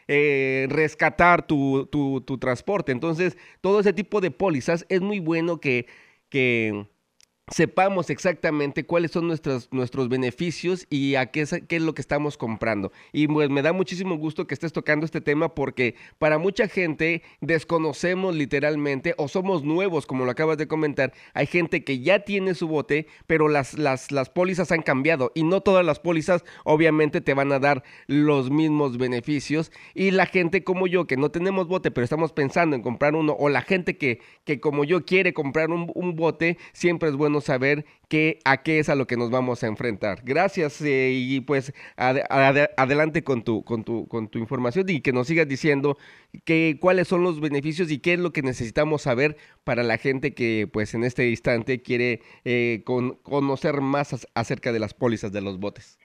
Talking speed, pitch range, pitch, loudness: 190 wpm, 130-170 Hz, 150 Hz, -23 LUFS